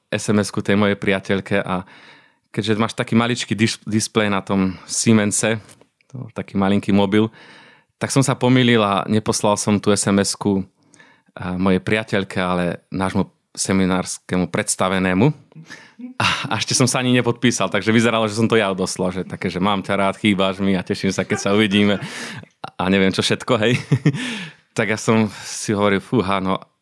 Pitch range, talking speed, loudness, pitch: 95-115 Hz, 155 wpm, -19 LUFS, 105 Hz